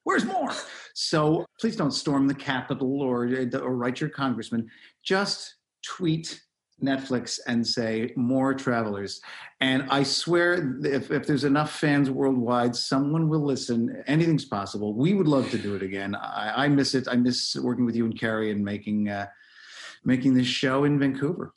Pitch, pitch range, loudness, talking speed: 130 Hz, 120-145 Hz, -26 LUFS, 165 wpm